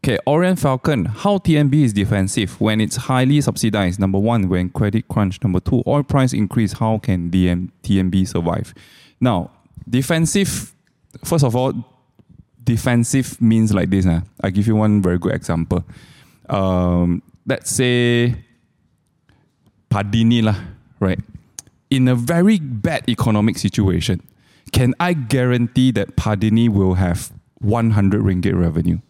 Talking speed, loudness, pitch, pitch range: 130 wpm, -18 LUFS, 110 Hz, 95-130 Hz